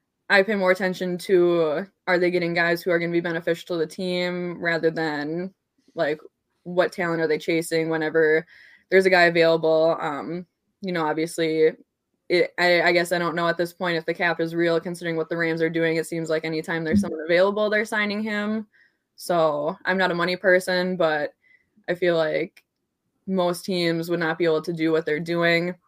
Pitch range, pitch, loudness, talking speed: 165-180 Hz, 170 Hz, -23 LUFS, 200 wpm